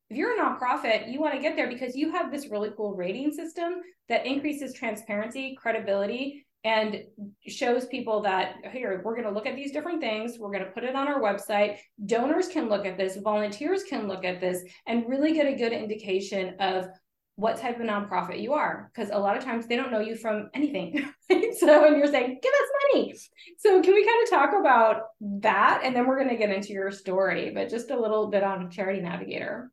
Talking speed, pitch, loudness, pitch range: 220 wpm, 230 Hz, -26 LUFS, 205-280 Hz